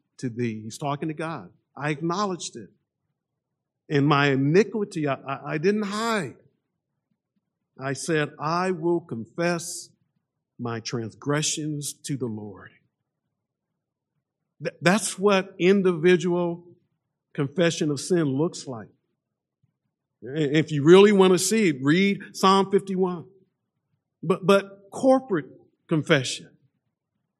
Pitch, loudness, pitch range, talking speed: 160 Hz, -23 LUFS, 145-185 Hz, 110 wpm